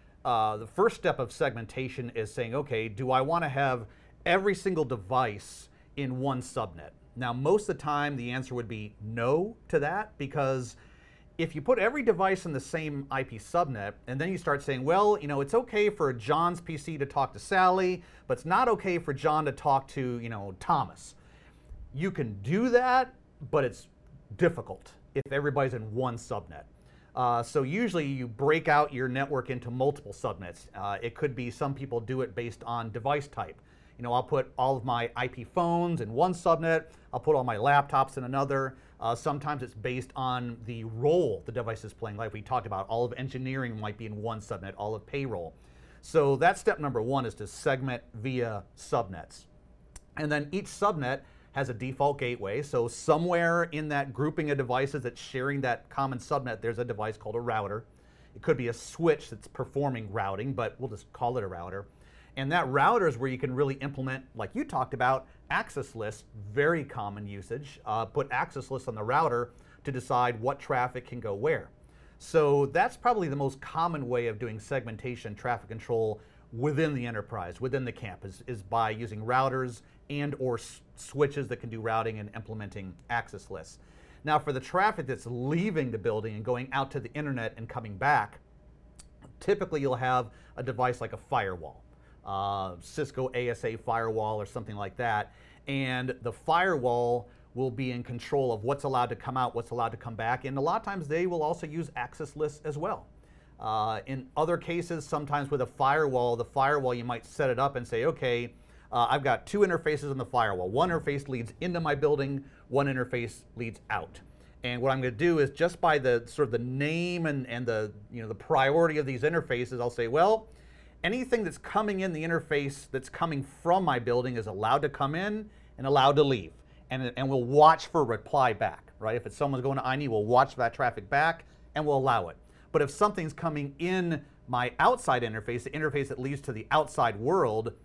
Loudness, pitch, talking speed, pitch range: -30 LUFS, 130 Hz, 195 wpm, 115-150 Hz